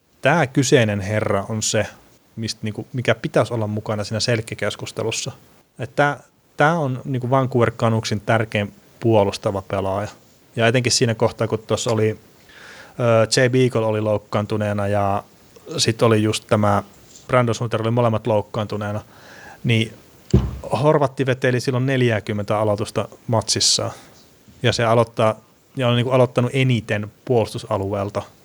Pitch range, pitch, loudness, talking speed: 105-125 Hz, 115 Hz, -20 LUFS, 110 wpm